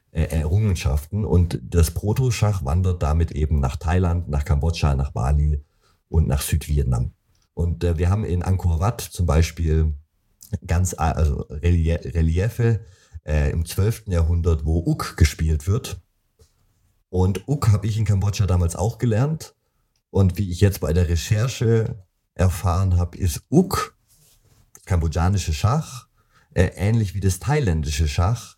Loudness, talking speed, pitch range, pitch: -22 LUFS, 135 wpm, 80-105 Hz, 90 Hz